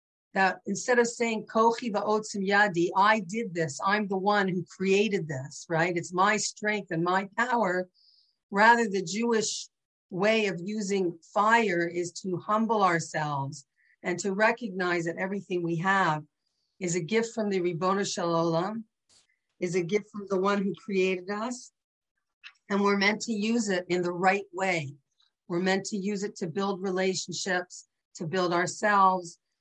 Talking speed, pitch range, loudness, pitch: 160 wpm, 180-210 Hz, -27 LUFS, 195 Hz